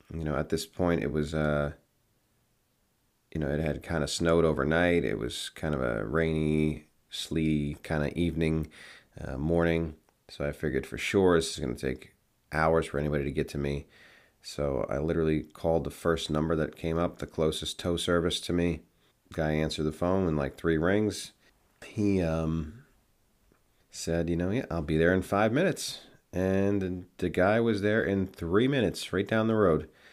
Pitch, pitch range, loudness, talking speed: 80 Hz, 75-95 Hz, -29 LUFS, 185 wpm